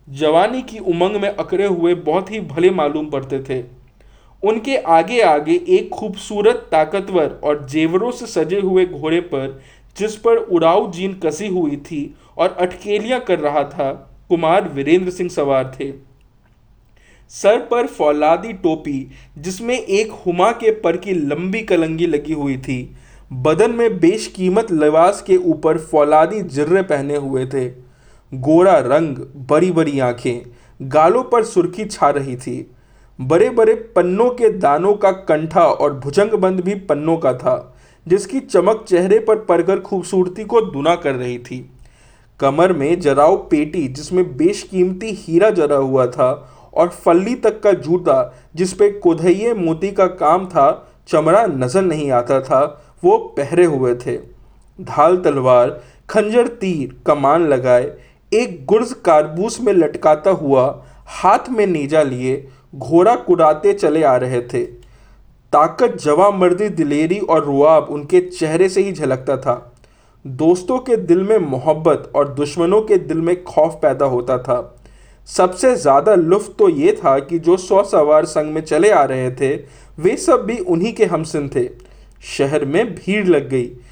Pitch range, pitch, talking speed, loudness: 140-200 Hz, 170 Hz, 150 wpm, -16 LUFS